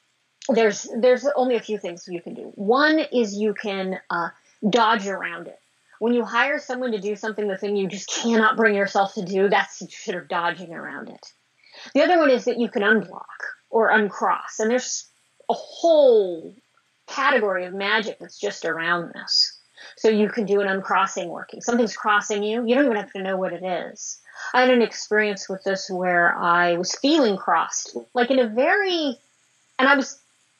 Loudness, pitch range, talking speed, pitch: -21 LUFS, 195-250 Hz, 190 wpm, 215 Hz